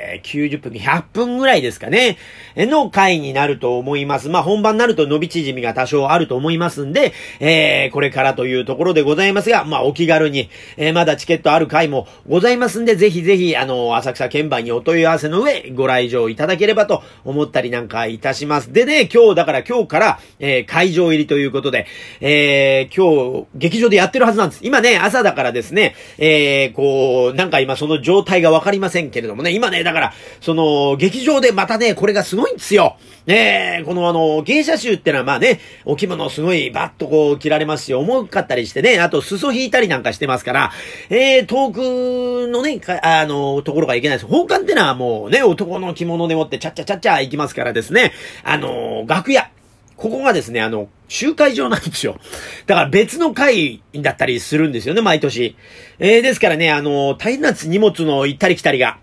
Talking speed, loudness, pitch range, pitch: 400 characters per minute, -15 LUFS, 140-210 Hz, 160 Hz